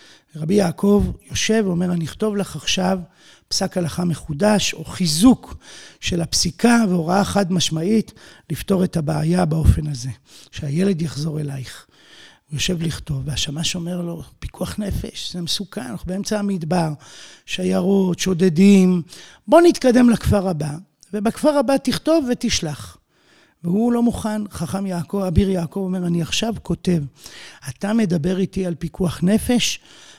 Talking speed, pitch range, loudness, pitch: 130 wpm, 165-205 Hz, -20 LUFS, 185 Hz